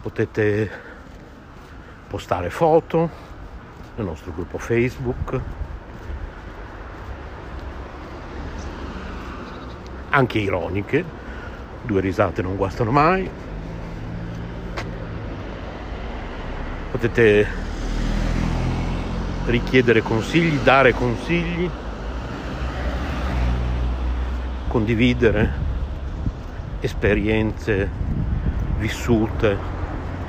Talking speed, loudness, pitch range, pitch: 45 wpm, -22 LUFS, 70-110 Hz, 90 Hz